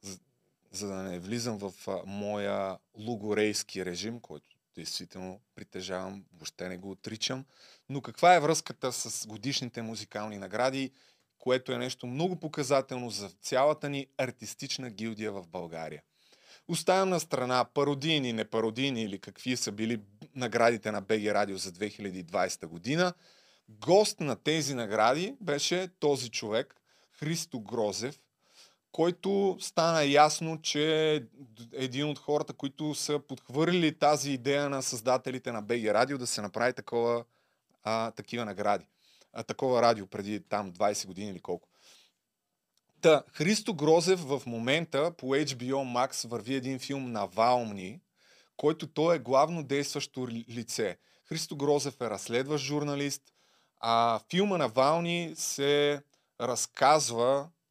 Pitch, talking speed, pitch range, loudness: 130 Hz, 130 wpm, 110-150 Hz, -30 LUFS